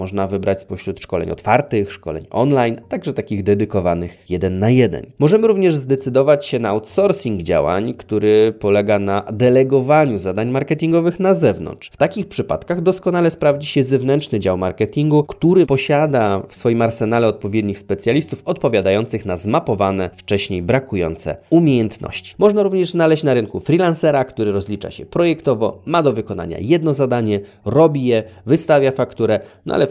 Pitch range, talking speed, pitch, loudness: 100-150 Hz, 145 wpm, 120 Hz, -17 LUFS